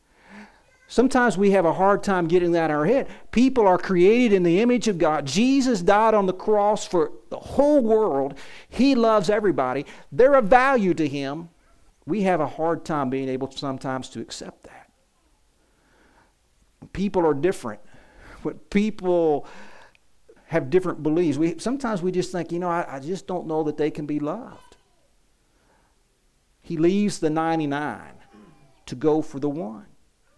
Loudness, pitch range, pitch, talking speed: -22 LUFS, 155-210 Hz, 175 Hz, 155 wpm